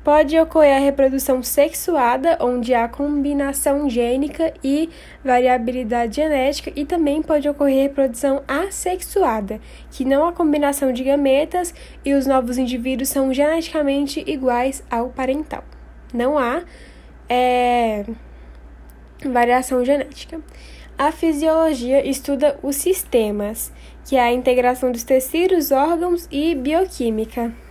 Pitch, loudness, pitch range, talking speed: 275 Hz, -19 LUFS, 250-305 Hz, 115 wpm